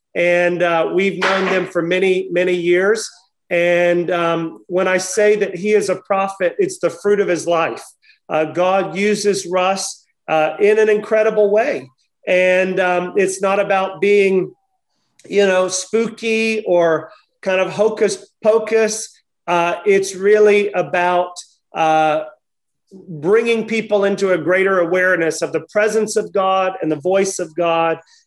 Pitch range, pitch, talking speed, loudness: 175-205 Hz, 190 Hz, 145 wpm, -17 LUFS